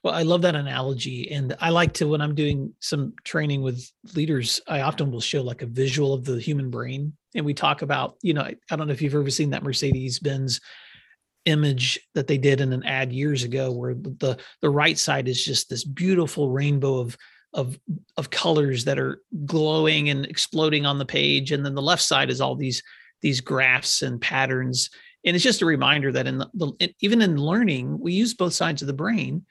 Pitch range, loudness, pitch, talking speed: 130-155 Hz, -23 LUFS, 140 Hz, 210 wpm